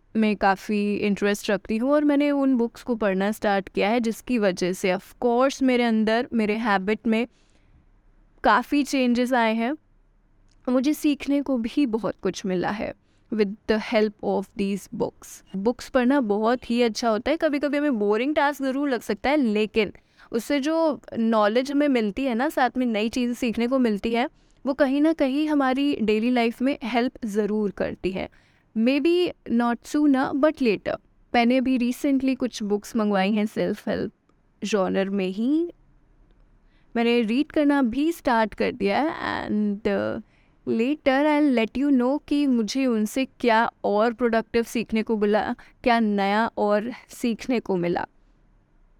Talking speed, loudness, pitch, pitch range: 165 wpm, -23 LUFS, 235 Hz, 215-270 Hz